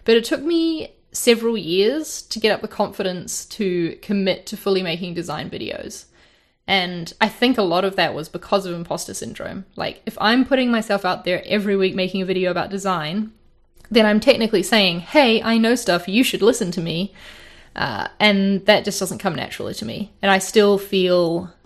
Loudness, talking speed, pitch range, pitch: -20 LUFS, 195 wpm, 185-220 Hz, 200 Hz